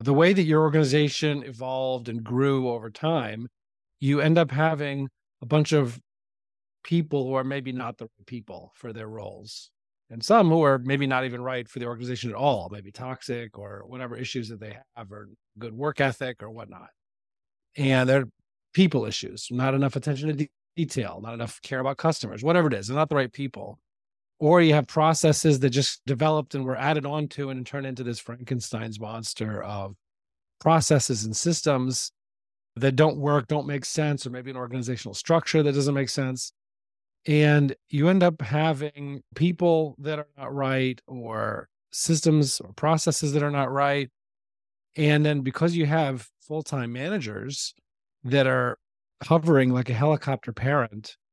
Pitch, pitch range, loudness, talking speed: 135 Hz, 120-150 Hz, -25 LUFS, 170 wpm